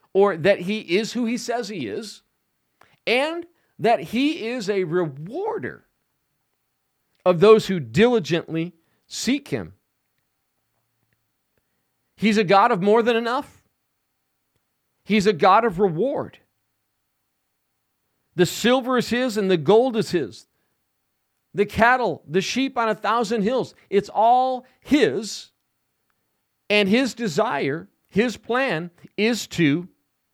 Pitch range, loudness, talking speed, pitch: 180-235 Hz, -21 LUFS, 120 wpm, 210 Hz